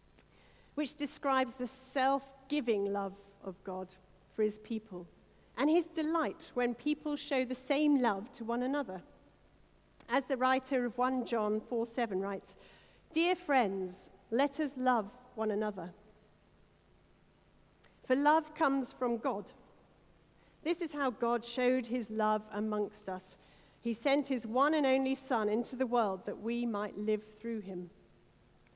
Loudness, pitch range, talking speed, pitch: -34 LUFS, 210-270 Hz, 145 wpm, 240 Hz